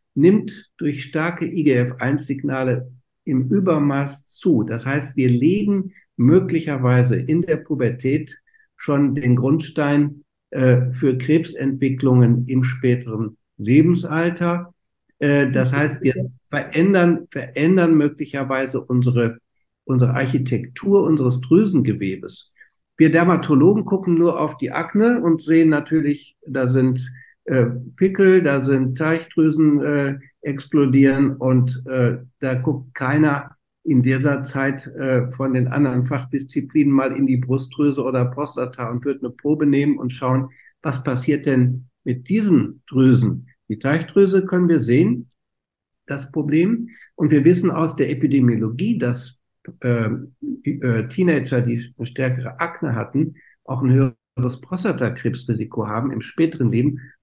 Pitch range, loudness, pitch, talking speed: 125-155 Hz, -19 LUFS, 140 Hz, 120 wpm